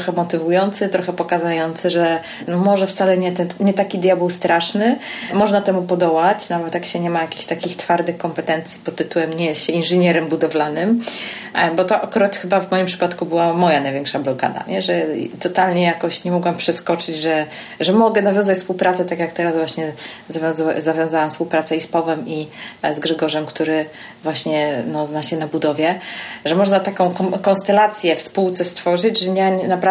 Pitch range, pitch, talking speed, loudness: 160-185 Hz, 170 Hz, 175 wpm, -18 LUFS